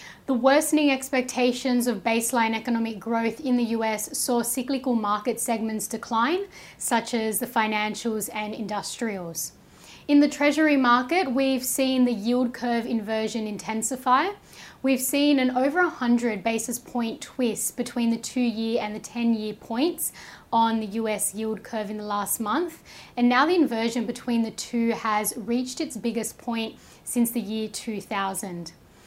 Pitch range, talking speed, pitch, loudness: 220-255 Hz, 155 wpm, 235 Hz, -25 LUFS